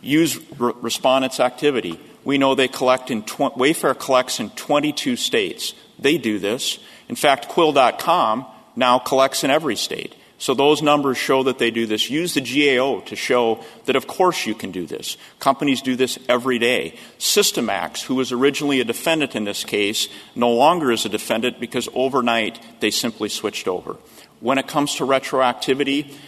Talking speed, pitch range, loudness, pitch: 170 wpm, 120-140 Hz, -20 LUFS, 130 Hz